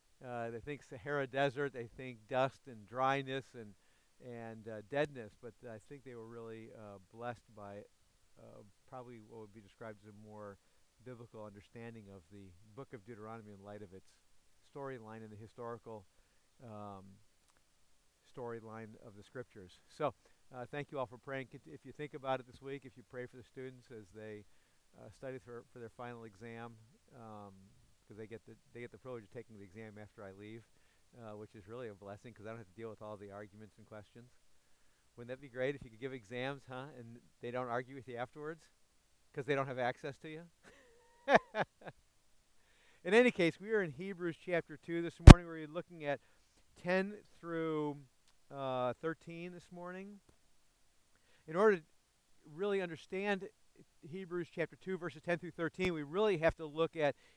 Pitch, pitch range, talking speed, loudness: 120 Hz, 110-145 Hz, 185 wpm, -35 LUFS